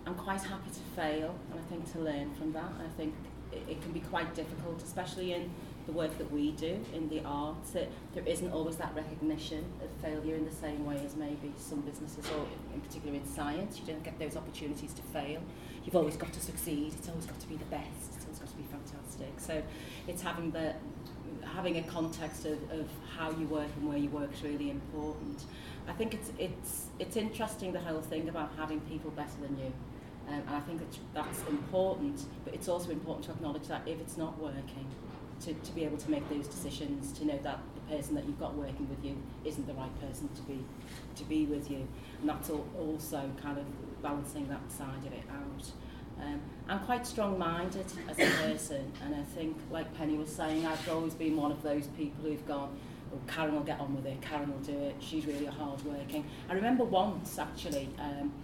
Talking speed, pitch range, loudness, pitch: 215 wpm, 145-160 Hz, -38 LUFS, 150 Hz